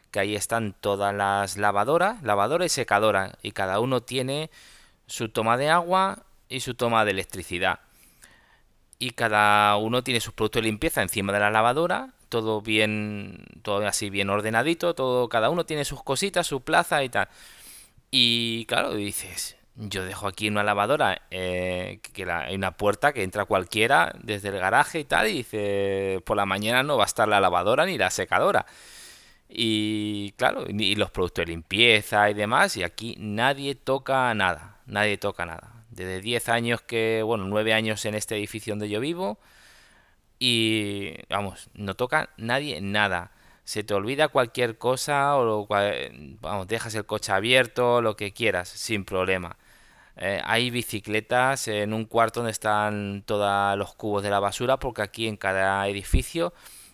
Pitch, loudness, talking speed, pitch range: 105 Hz, -25 LUFS, 165 wpm, 100-120 Hz